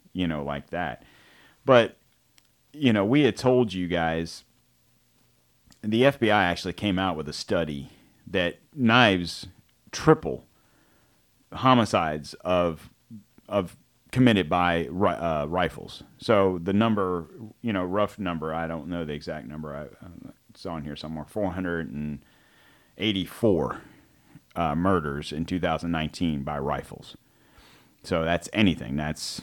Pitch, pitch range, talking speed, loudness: 90 Hz, 80-110 Hz, 130 wpm, -26 LUFS